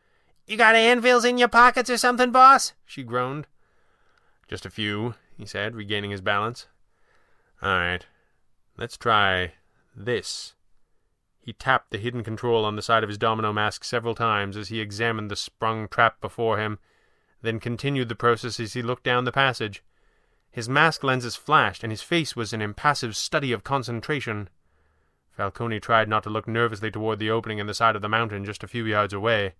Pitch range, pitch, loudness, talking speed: 105-125 Hz, 115 Hz, -23 LUFS, 180 wpm